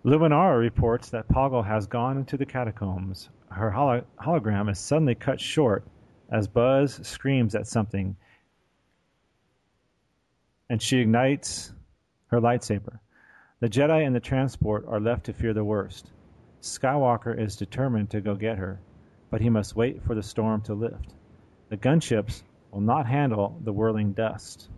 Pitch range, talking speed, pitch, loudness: 105-125 Hz, 145 wpm, 115 Hz, -26 LUFS